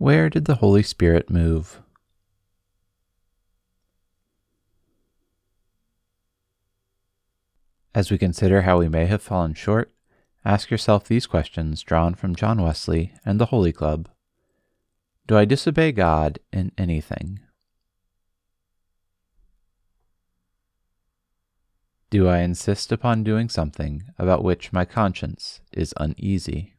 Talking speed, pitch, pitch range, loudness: 100 wpm, 95 Hz, 90-100 Hz, -21 LUFS